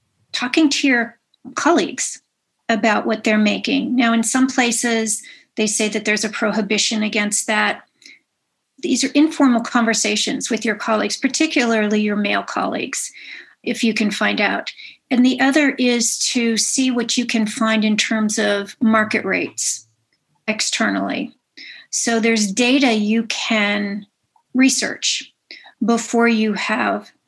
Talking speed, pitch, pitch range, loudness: 135 wpm, 225 Hz, 215-250 Hz, -18 LUFS